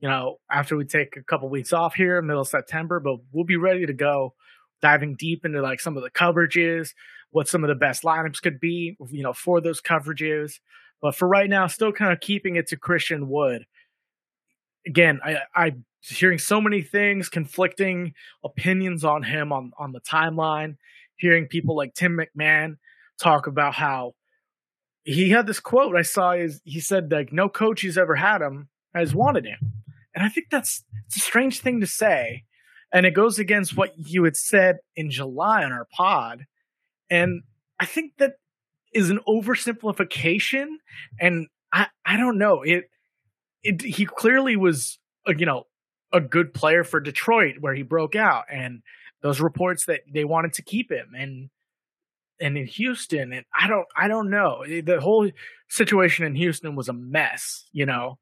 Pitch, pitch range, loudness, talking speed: 165 Hz, 145-195 Hz, -22 LUFS, 180 wpm